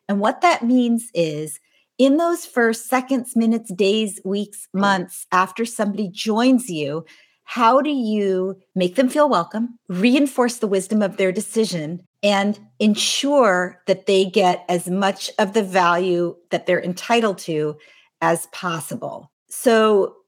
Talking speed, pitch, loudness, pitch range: 140 wpm, 205 Hz, -20 LUFS, 180-235 Hz